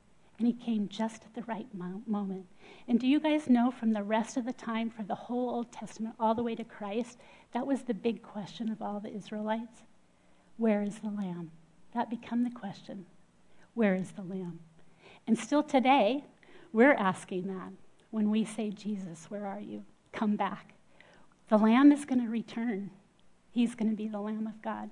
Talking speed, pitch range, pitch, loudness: 190 wpm, 200-235 Hz, 220 Hz, -31 LUFS